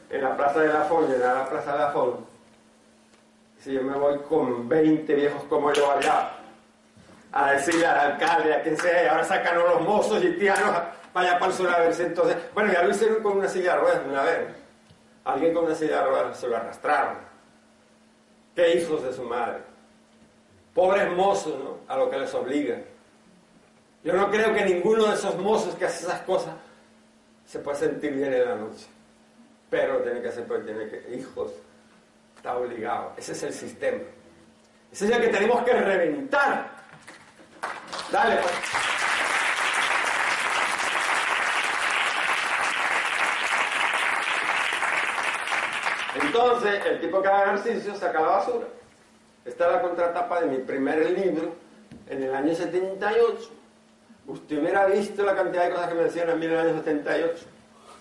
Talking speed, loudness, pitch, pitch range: 160 wpm, -24 LUFS, 180 Hz, 160-220 Hz